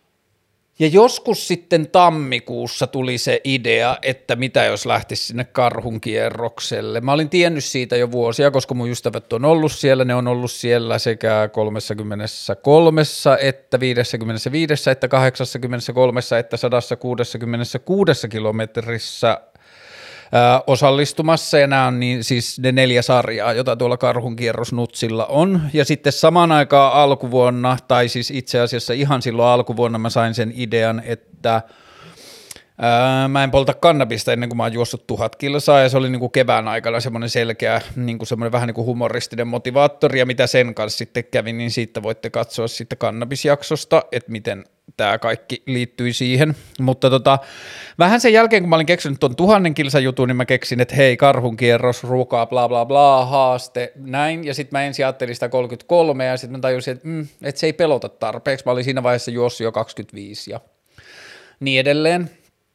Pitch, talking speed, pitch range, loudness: 125 Hz, 155 wpm, 120-140 Hz, -17 LUFS